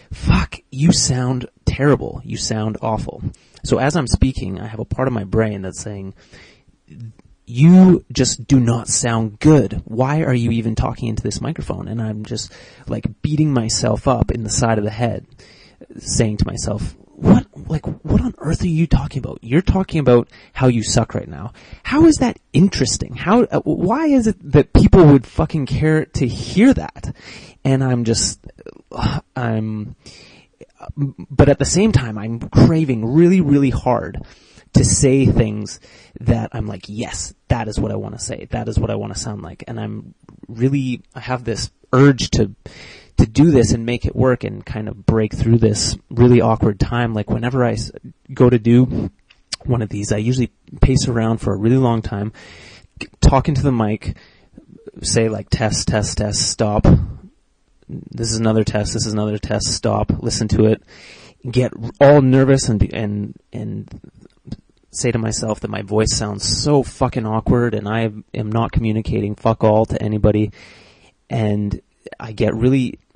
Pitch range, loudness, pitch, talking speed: 105-130 Hz, -17 LUFS, 115 Hz, 175 wpm